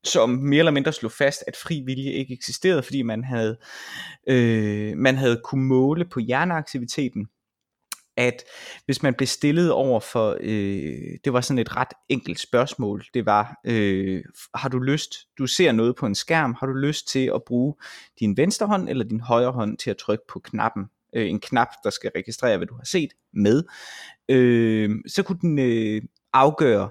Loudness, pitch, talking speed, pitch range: -23 LUFS, 125 Hz, 185 wpm, 110-140 Hz